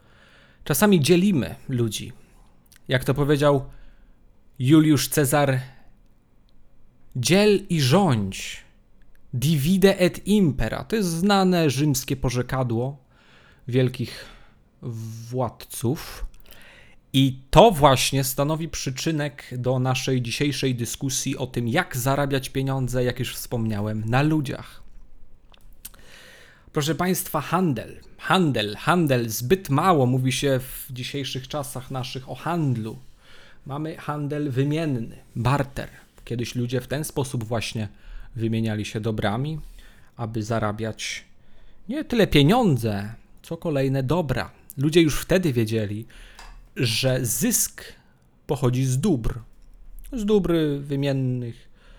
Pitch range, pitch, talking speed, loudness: 120-155 Hz, 130 Hz, 100 wpm, -23 LUFS